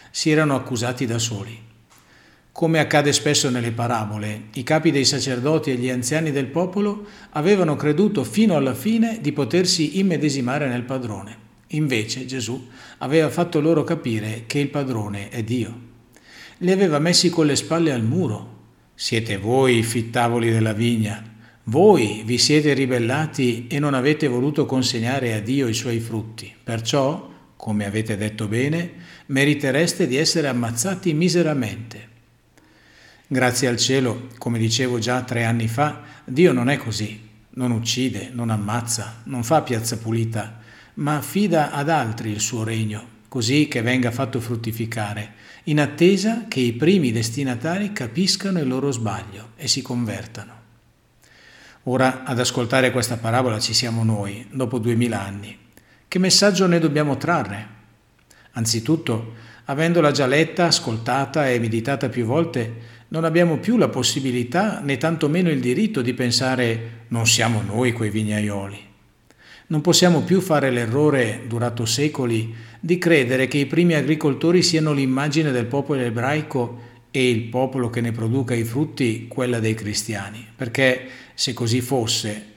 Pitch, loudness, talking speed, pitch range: 125 Hz, -21 LUFS, 145 wpm, 115-150 Hz